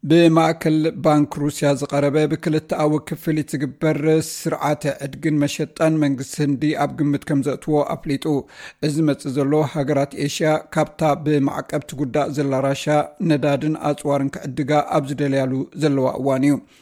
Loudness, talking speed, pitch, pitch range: -20 LUFS, 120 wpm, 150 Hz, 140-155 Hz